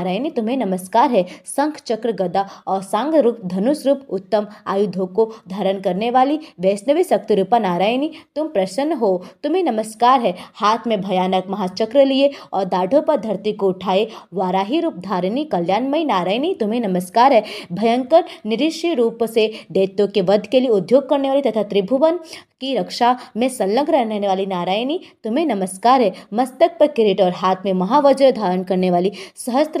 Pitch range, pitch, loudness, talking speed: 190-275 Hz, 225 Hz, -18 LUFS, 130 wpm